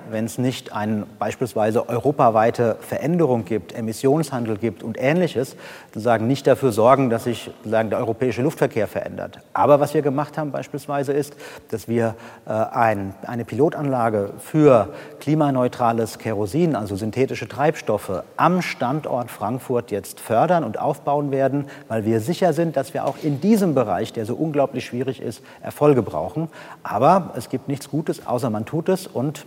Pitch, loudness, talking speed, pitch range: 130 Hz, -21 LUFS, 155 wpm, 115-145 Hz